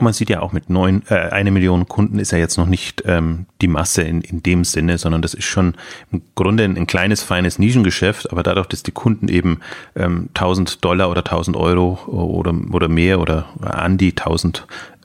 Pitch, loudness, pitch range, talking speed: 90 Hz, -17 LUFS, 85-95 Hz, 205 wpm